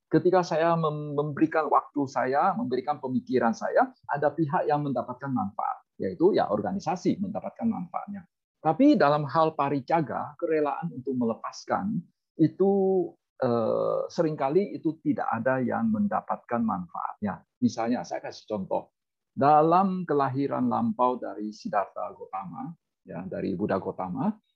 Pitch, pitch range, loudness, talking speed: 160 Hz, 140-195 Hz, -27 LUFS, 115 wpm